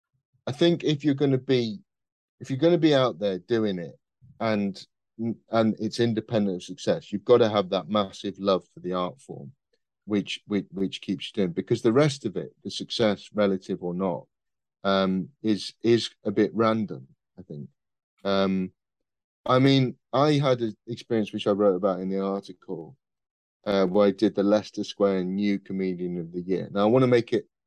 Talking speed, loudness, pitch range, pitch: 190 wpm, -25 LUFS, 95-120 Hz, 105 Hz